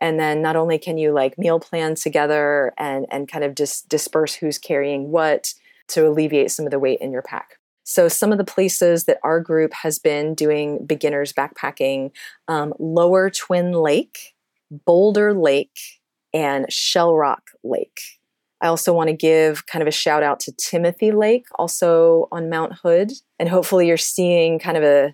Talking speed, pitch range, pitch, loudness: 180 wpm, 150-170 Hz, 160 Hz, -19 LUFS